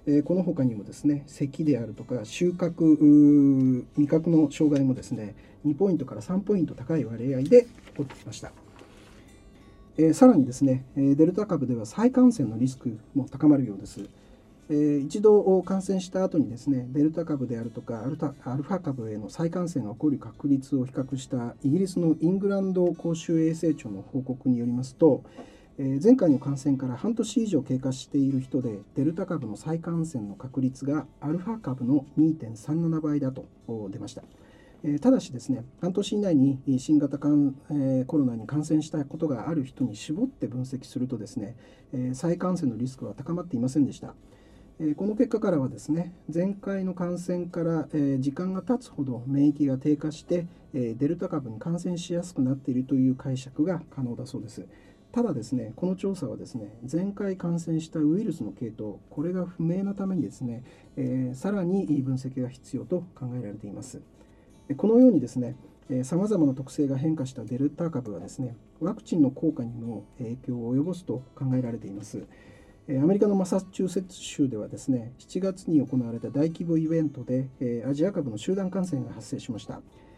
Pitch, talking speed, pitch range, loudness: 145 Hz, 355 characters per minute, 125-170 Hz, -27 LUFS